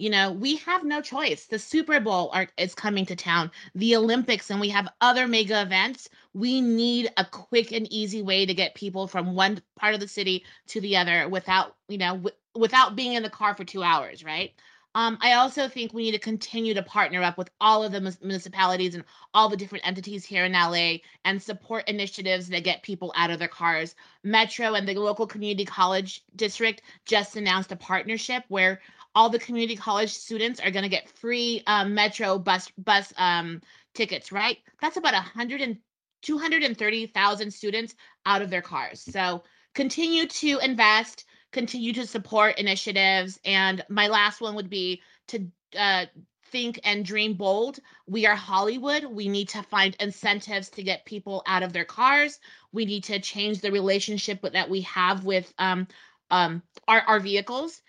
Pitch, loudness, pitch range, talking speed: 205 Hz, -25 LUFS, 190-225 Hz, 180 wpm